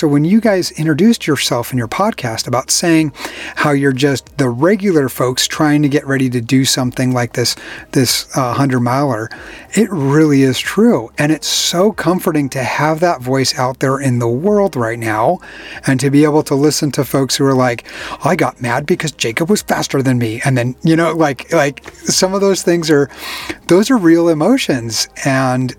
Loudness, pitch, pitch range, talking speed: -14 LUFS, 145 Hz, 130-170 Hz, 200 wpm